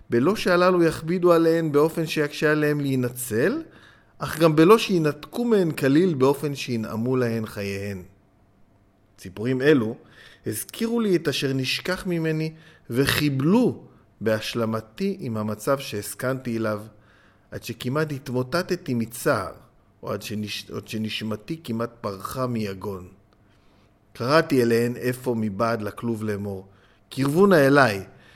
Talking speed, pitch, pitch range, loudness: 110 wpm, 125 Hz, 105-155 Hz, -23 LUFS